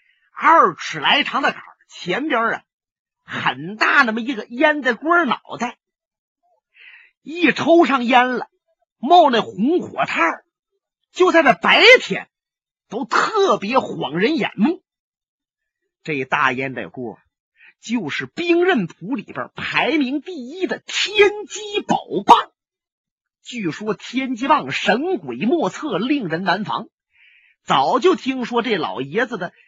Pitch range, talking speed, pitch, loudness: 230-360 Hz, 175 characters per minute, 295 Hz, -18 LUFS